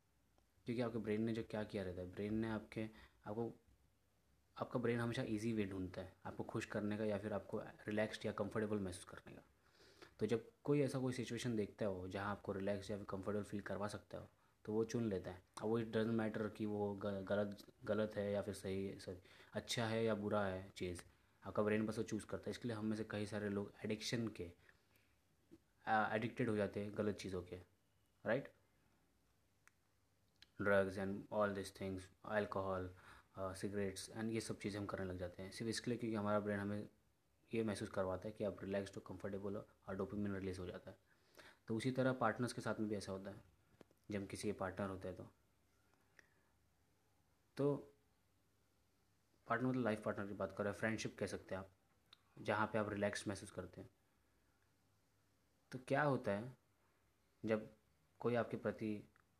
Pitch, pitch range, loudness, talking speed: 100 Hz, 95-110 Hz, -44 LUFS, 190 wpm